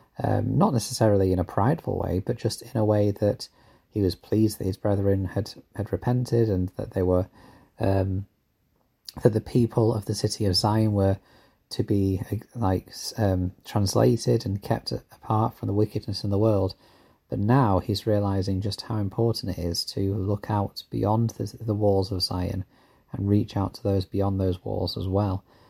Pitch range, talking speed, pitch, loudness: 95-115 Hz, 180 wpm, 105 Hz, -26 LUFS